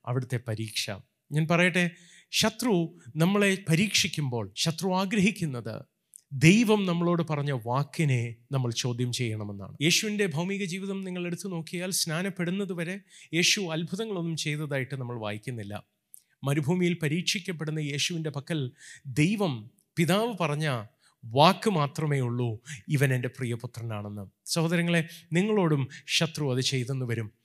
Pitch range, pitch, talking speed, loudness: 130-180 Hz, 155 Hz, 105 wpm, -28 LUFS